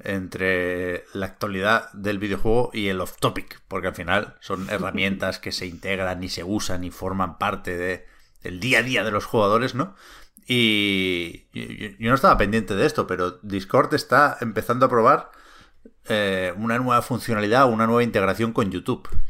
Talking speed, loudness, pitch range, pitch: 170 wpm, -22 LUFS, 95-115 Hz, 100 Hz